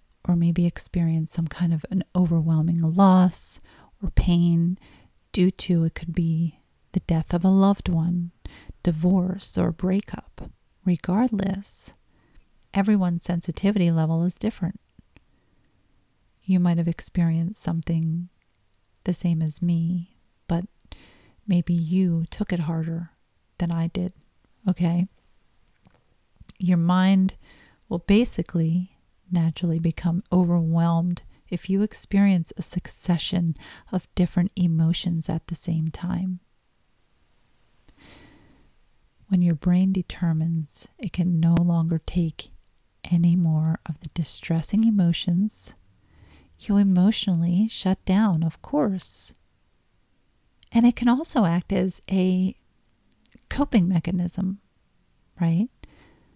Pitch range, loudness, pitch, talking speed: 165-185 Hz, -24 LUFS, 175 Hz, 105 wpm